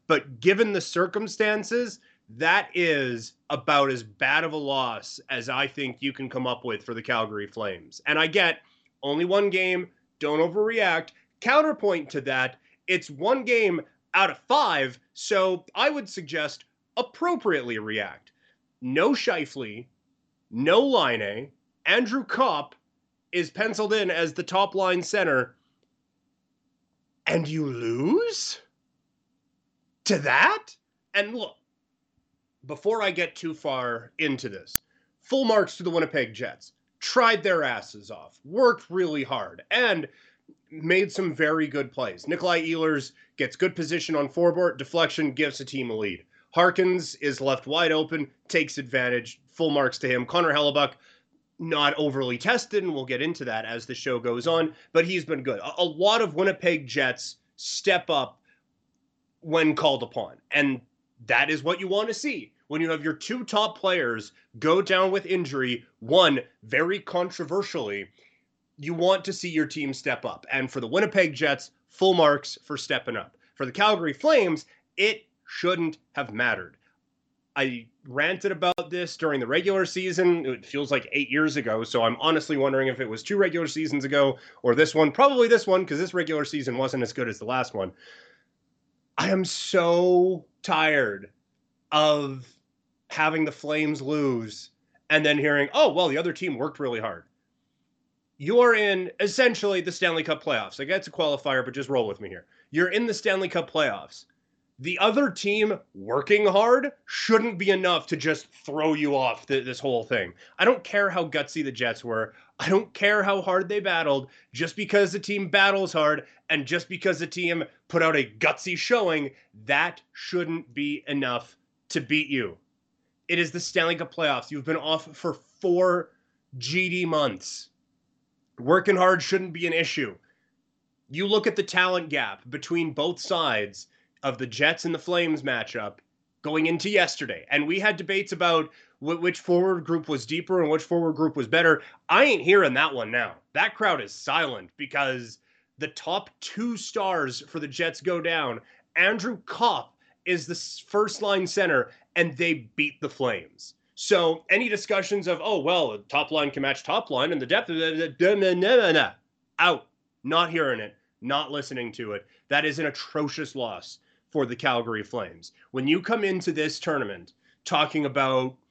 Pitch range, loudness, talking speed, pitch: 140-190 Hz, -25 LUFS, 170 wpm, 160 Hz